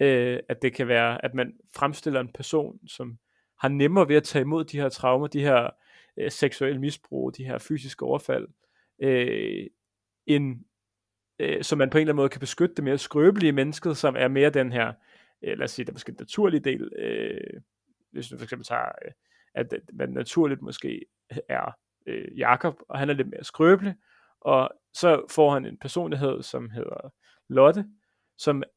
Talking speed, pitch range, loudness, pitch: 185 wpm, 130-160 Hz, -25 LUFS, 140 Hz